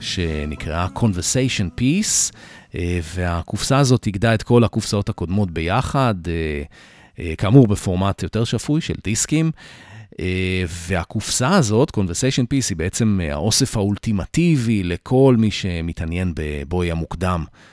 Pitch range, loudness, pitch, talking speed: 90-115 Hz, -20 LUFS, 100 Hz, 100 wpm